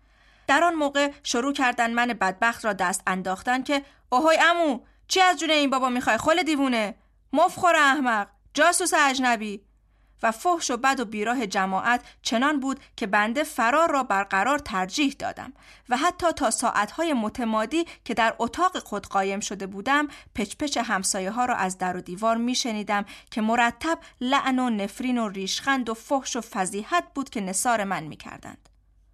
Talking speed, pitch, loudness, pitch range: 160 wpm, 245 Hz, -24 LUFS, 210-290 Hz